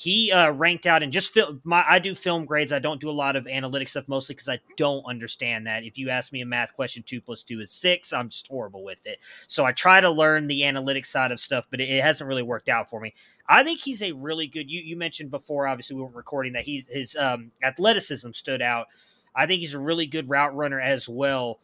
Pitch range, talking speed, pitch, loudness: 125-160 Hz, 255 wpm, 140 Hz, -23 LUFS